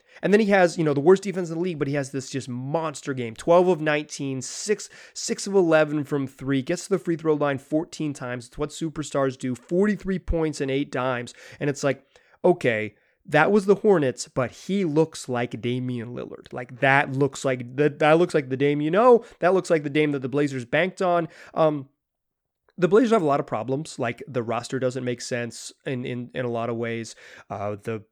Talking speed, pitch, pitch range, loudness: 220 wpm, 145 Hz, 130-170 Hz, -24 LUFS